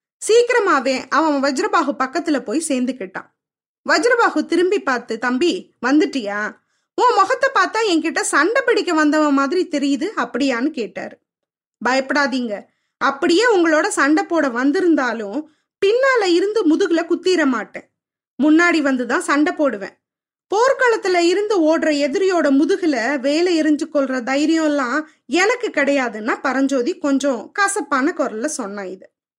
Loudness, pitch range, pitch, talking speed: -17 LUFS, 275-360 Hz, 305 Hz, 110 wpm